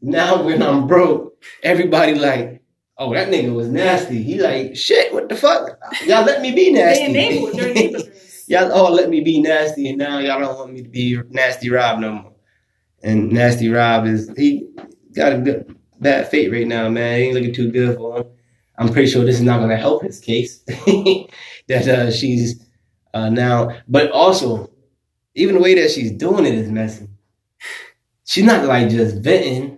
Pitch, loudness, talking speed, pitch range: 125 Hz, -16 LUFS, 180 wpm, 115-160 Hz